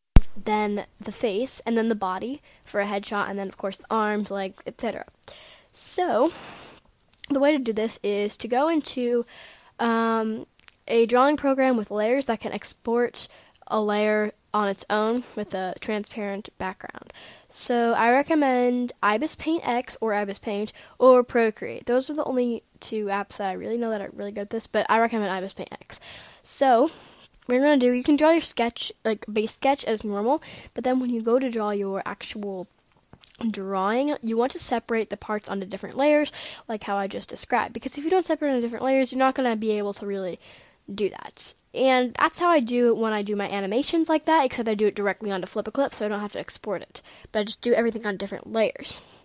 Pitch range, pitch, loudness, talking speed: 205-255 Hz, 225 Hz, -25 LUFS, 210 wpm